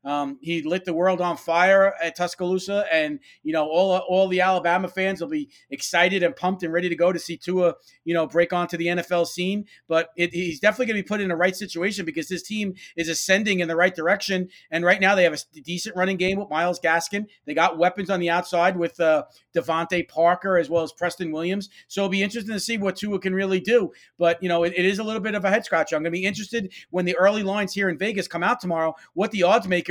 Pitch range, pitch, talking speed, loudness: 170-195 Hz, 180 Hz, 255 wpm, -23 LUFS